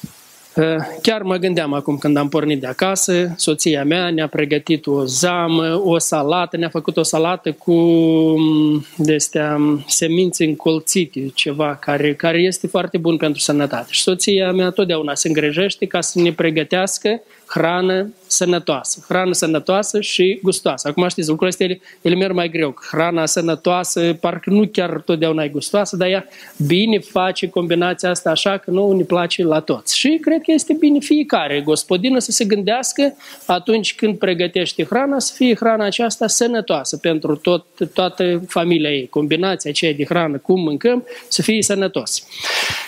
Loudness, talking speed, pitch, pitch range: -17 LUFS, 155 wpm, 175 Hz, 160-190 Hz